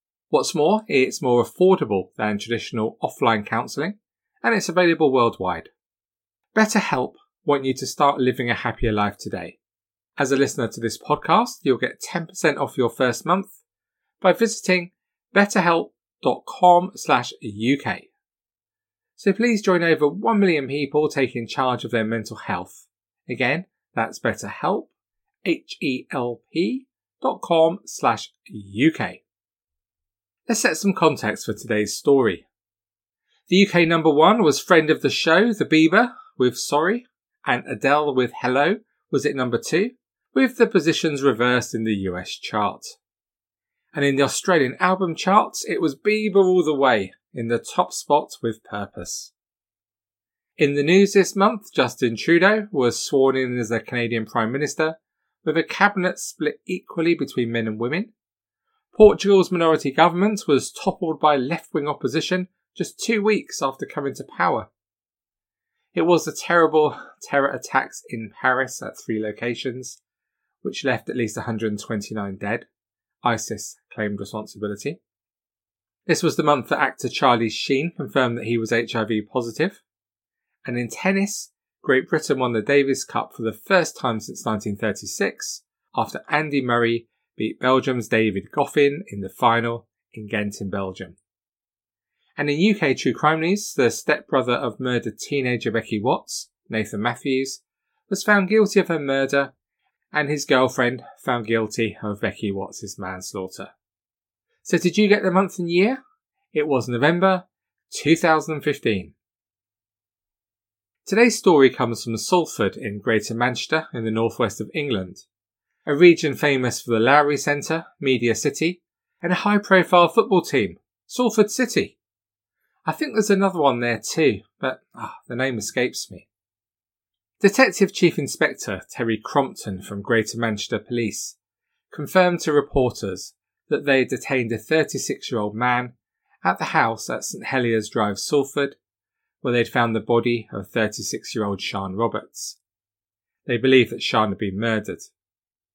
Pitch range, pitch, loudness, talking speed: 110-175 Hz, 135 Hz, -21 LUFS, 140 wpm